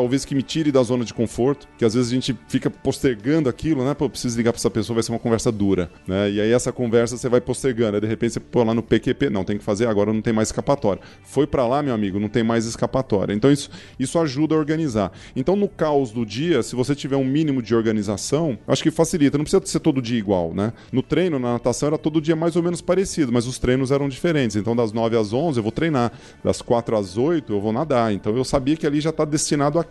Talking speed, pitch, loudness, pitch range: 265 wpm, 125 Hz, -21 LUFS, 115-145 Hz